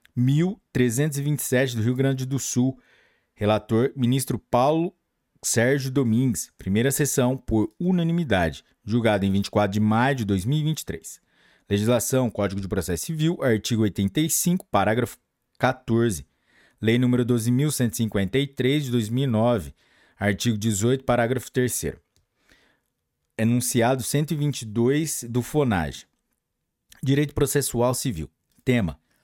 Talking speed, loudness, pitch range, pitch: 100 wpm, -23 LUFS, 110-135 Hz, 125 Hz